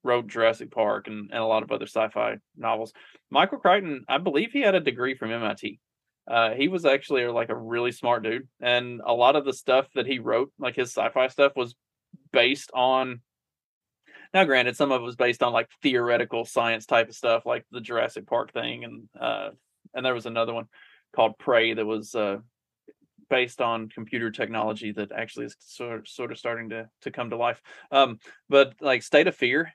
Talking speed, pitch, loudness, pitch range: 205 wpm, 120 Hz, -25 LUFS, 115-130 Hz